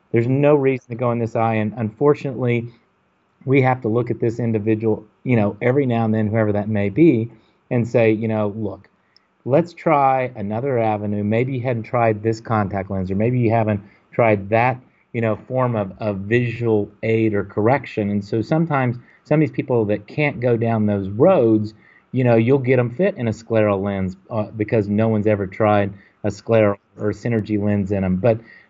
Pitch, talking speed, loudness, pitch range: 110 Hz, 200 wpm, -20 LUFS, 105-120 Hz